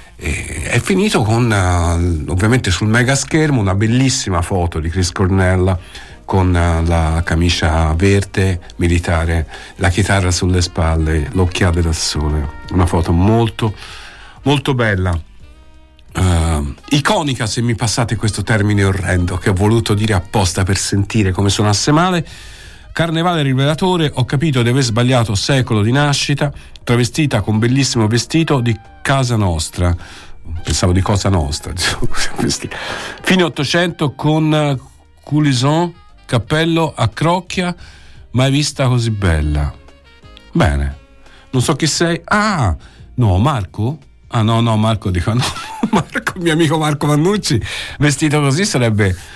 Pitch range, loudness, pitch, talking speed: 90-140 Hz, -15 LUFS, 110 Hz, 130 wpm